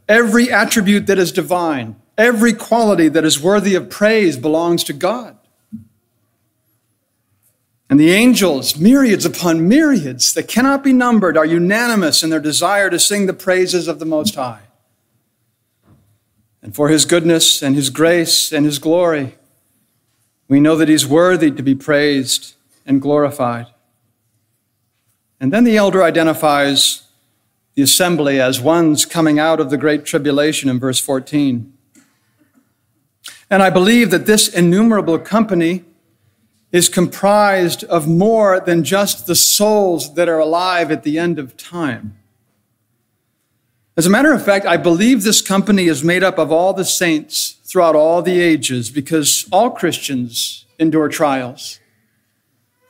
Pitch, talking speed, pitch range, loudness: 155 Hz, 140 wpm, 125-180 Hz, -13 LUFS